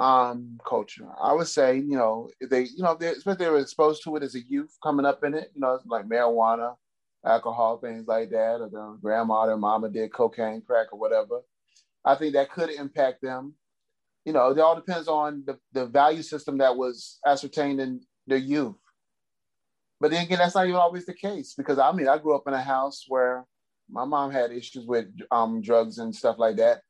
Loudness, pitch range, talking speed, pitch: -25 LUFS, 115-155 Hz, 210 wpm, 135 Hz